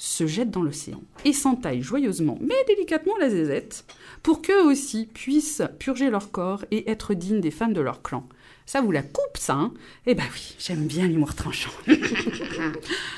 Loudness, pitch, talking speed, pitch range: -25 LUFS, 235 Hz, 180 wpm, 180-290 Hz